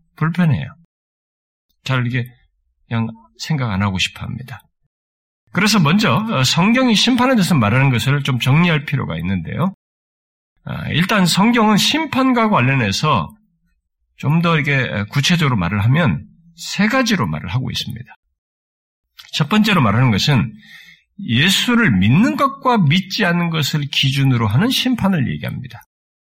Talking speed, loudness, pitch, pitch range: 280 characters per minute, -16 LUFS, 145 Hz, 115-195 Hz